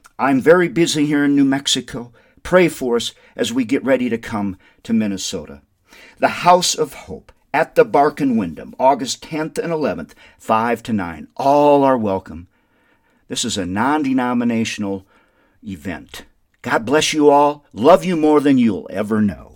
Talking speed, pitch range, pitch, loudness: 165 wpm, 110-165 Hz, 135 Hz, -17 LUFS